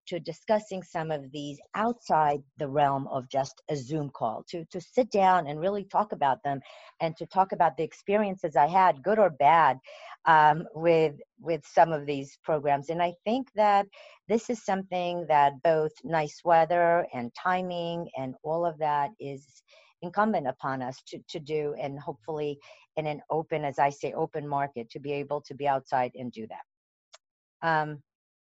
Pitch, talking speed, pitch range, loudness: 155 Hz, 175 wpm, 140-175 Hz, -28 LUFS